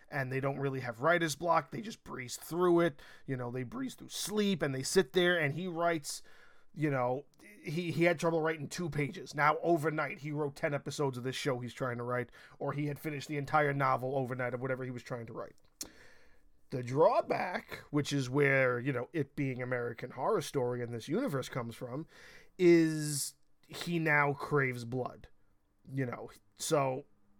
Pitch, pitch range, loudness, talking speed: 140 Hz, 130-160 Hz, -33 LUFS, 190 wpm